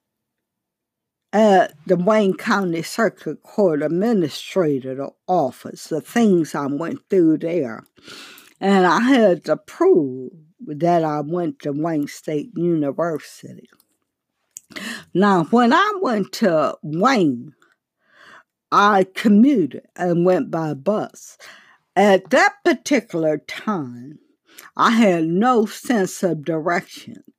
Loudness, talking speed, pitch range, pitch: -19 LUFS, 105 wpm, 155-220 Hz, 180 Hz